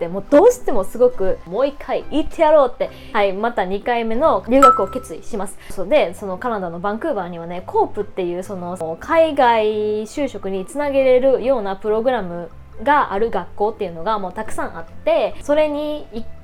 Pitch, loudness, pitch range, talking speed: 225 Hz, -18 LUFS, 195-290 Hz, 380 characters per minute